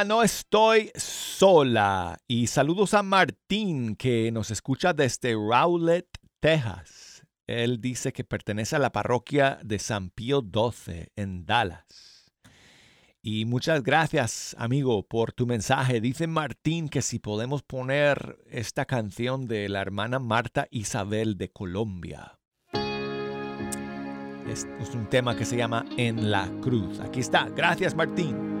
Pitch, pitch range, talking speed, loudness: 120 Hz, 105-140 Hz, 130 wpm, -26 LUFS